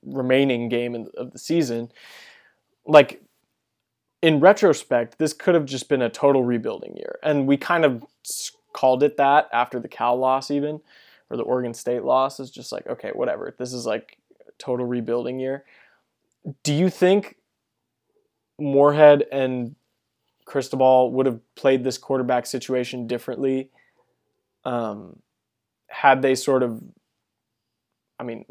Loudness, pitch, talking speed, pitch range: -21 LUFS, 135 Hz, 140 wpm, 125-150 Hz